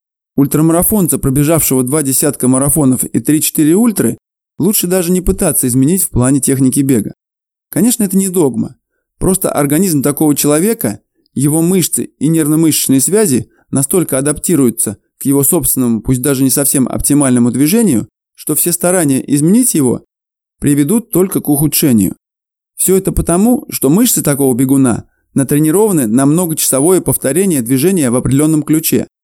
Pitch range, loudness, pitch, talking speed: 135-180 Hz, -11 LUFS, 150 Hz, 135 wpm